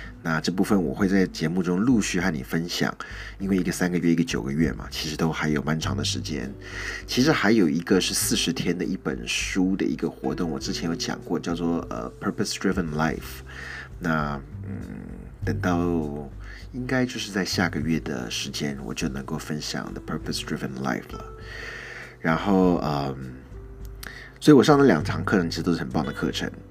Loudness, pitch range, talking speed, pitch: -25 LUFS, 75-95 Hz, 340 characters per minute, 85 Hz